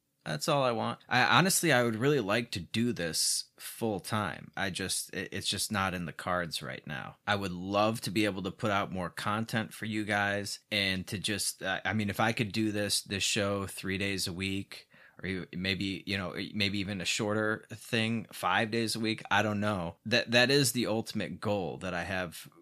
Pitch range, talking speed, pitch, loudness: 95-110 Hz, 220 wpm, 105 Hz, -31 LUFS